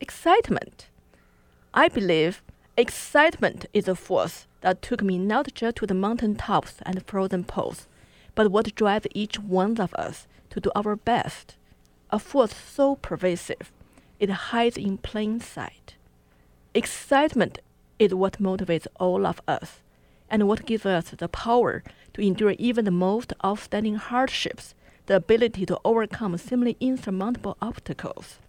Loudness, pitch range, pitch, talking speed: -25 LUFS, 185-230 Hz, 205 Hz, 140 wpm